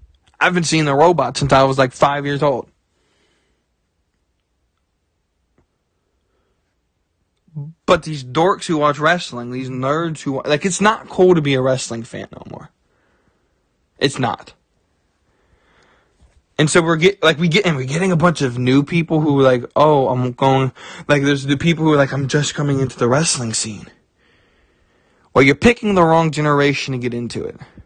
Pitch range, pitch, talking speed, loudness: 120-160 Hz, 140 Hz, 170 wpm, -16 LUFS